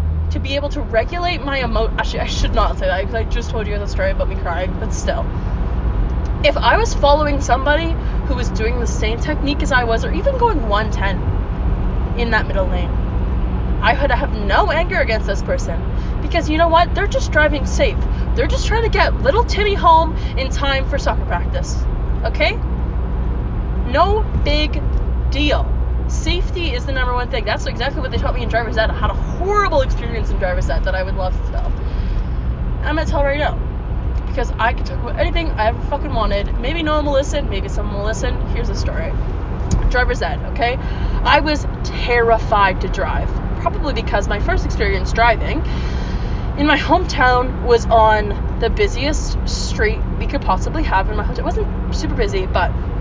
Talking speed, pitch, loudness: 190 wpm, 80 Hz, -18 LUFS